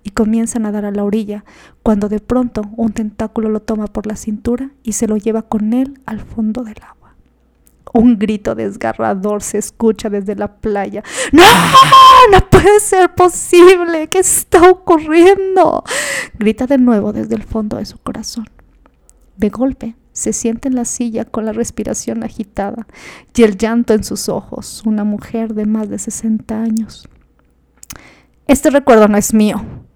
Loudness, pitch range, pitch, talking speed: -12 LUFS, 215-255 Hz, 225 Hz, 160 wpm